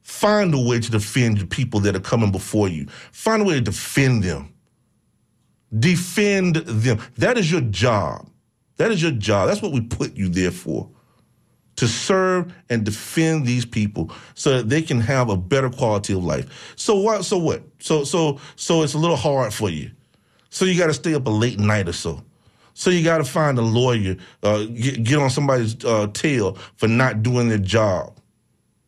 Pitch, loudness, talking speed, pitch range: 120 Hz, -20 LUFS, 195 wpm, 105-155 Hz